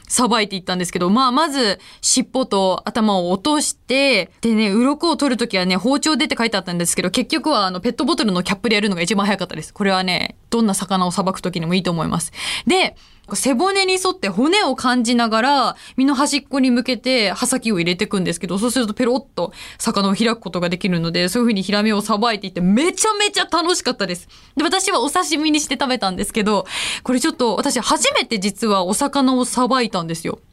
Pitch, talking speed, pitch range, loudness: 230 Hz, 445 characters per minute, 195-275 Hz, -18 LUFS